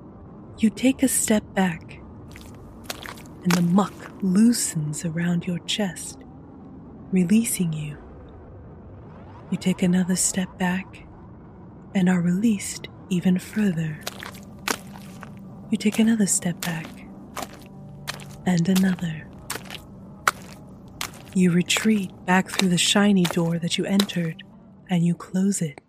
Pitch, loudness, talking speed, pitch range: 185 Hz, -23 LUFS, 105 wpm, 175-200 Hz